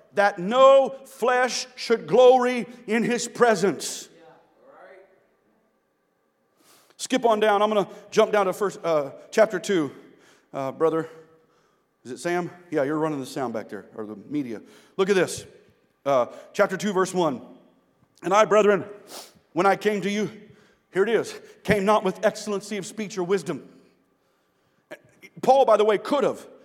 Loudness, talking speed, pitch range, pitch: -23 LUFS, 155 wpm, 180-235 Hz, 205 Hz